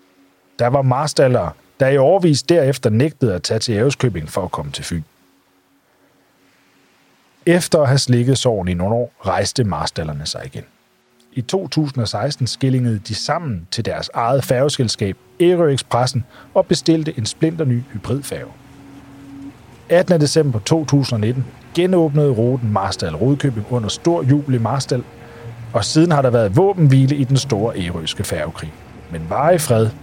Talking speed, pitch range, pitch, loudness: 145 wpm, 115-145 Hz, 130 Hz, -17 LUFS